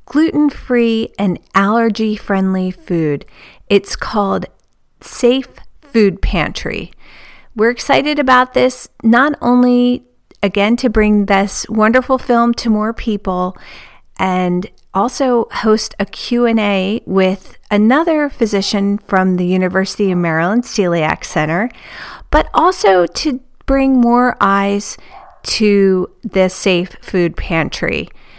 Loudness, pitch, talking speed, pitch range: -14 LUFS, 215 Hz, 105 wpm, 190-245 Hz